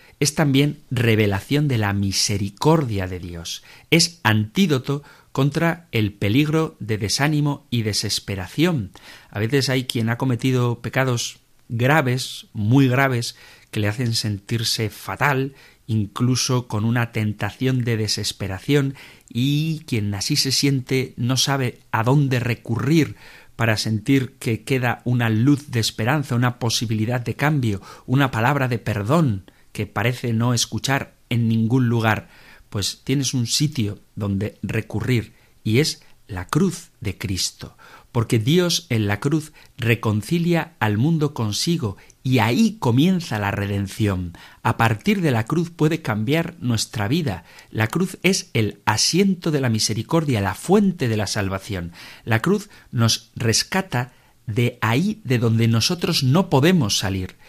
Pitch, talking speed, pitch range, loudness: 120 Hz, 135 wpm, 110-140 Hz, -21 LUFS